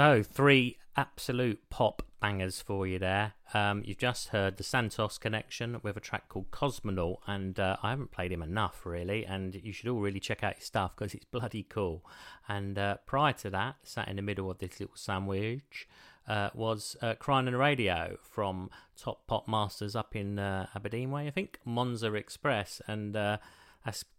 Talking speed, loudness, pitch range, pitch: 190 wpm, -33 LUFS, 100-120 Hz, 105 Hz